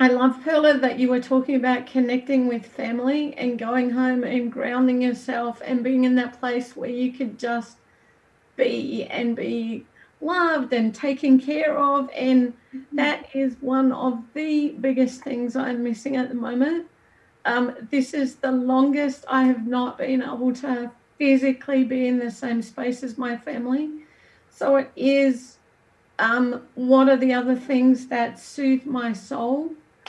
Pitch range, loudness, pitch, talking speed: 245-270 Hz, -23 LUFS, 255 Hz, 160 wpm